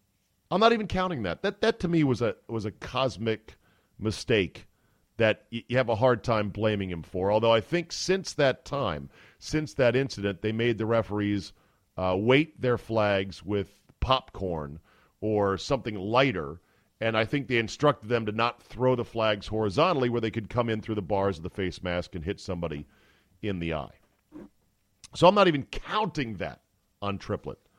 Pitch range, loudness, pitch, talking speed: 95-125 Hz, -28 LUFS, 110 Hz, 180 wpm